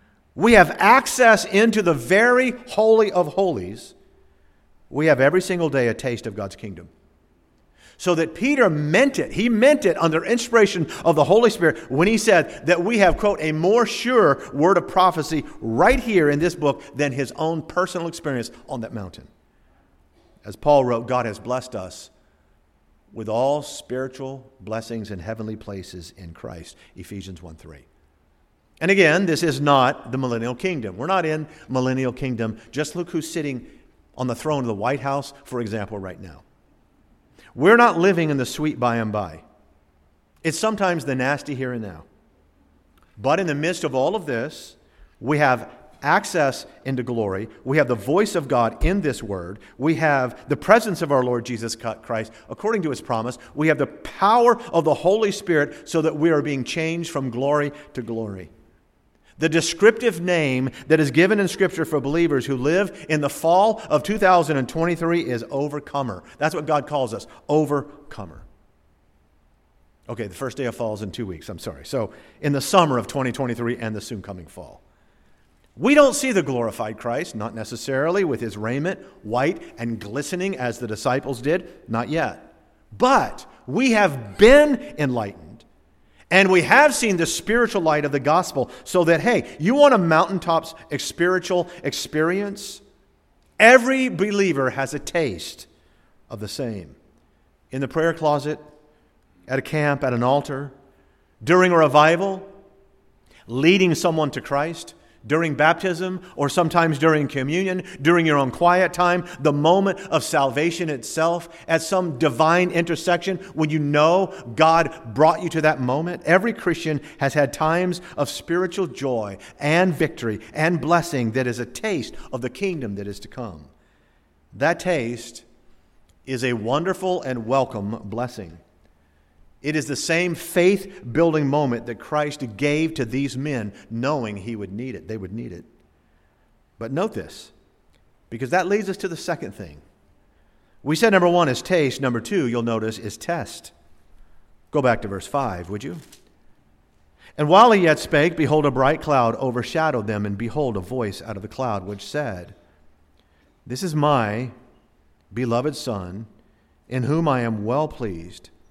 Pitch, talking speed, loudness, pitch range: 140 Hz, 165 wpm, -21 LUFS, 110-170 Hz